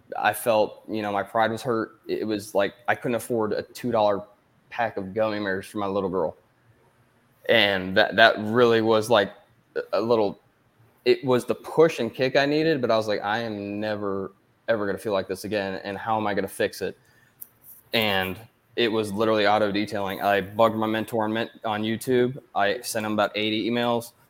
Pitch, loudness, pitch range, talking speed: 110 Hz, -24 LUFS, 100-115 Hz, 200 wpm